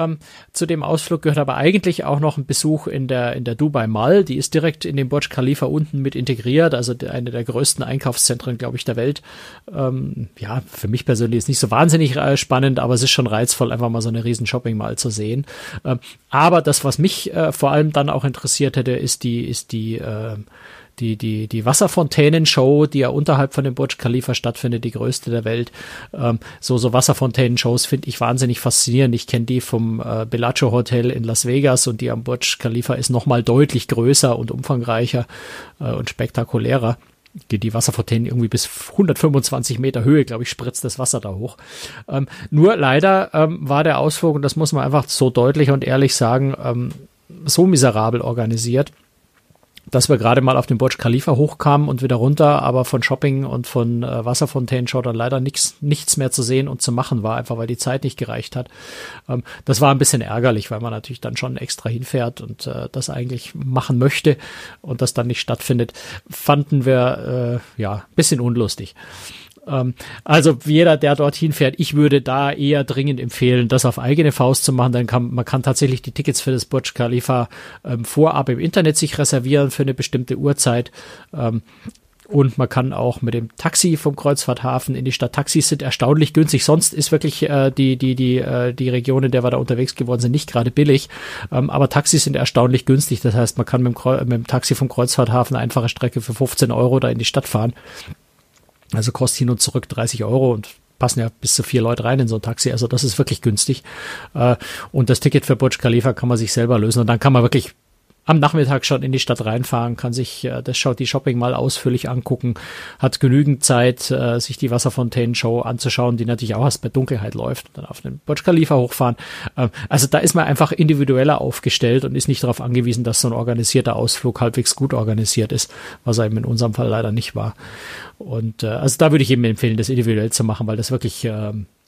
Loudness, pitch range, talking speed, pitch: -18 LUFS, 120-140 Hz, 200 wpm, 130 Hz